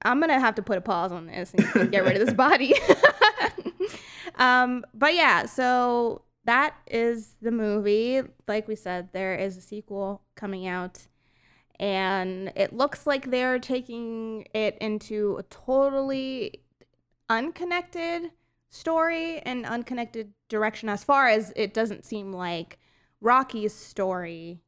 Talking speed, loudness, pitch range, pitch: 140 wpm, -25 LUFS, 200-265 Hz, 225 Hz